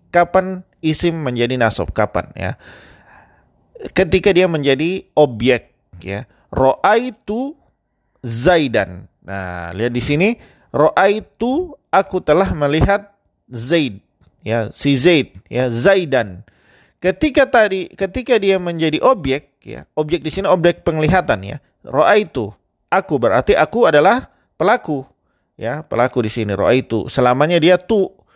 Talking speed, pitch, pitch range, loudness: 125 wpm, 155 Hz, 120-190 Hz, -16 LUFS